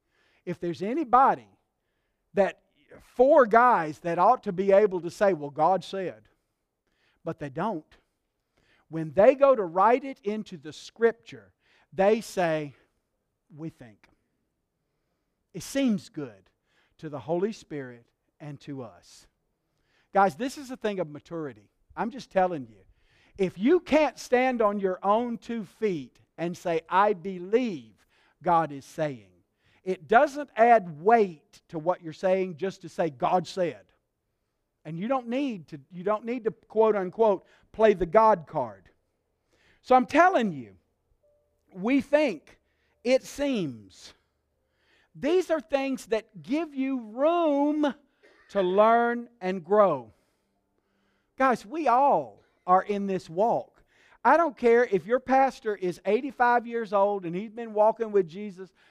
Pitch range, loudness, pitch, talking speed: 160-235 Hz, -26 LUFS, 195 Hz, 140 wpm